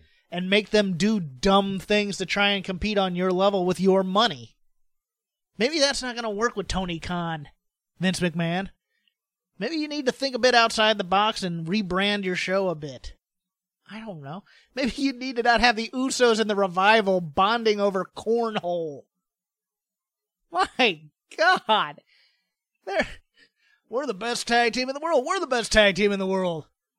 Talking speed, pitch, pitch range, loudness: 175 wpm, 205 Hz, 185-235 Hz, -23 LUFS